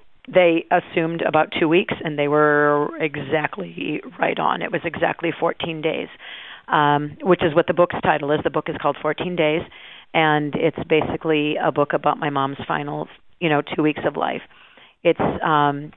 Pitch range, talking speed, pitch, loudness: 150-170 Hz, 175 wpm, 155 Hz, -21 LUFS